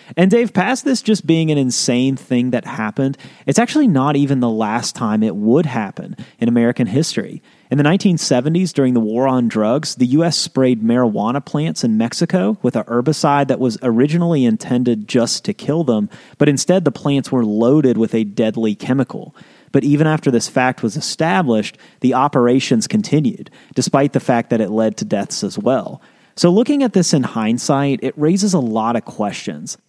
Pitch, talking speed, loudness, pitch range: 135 Hz, 185 wpm, -16 LUFS, 120-165 Hz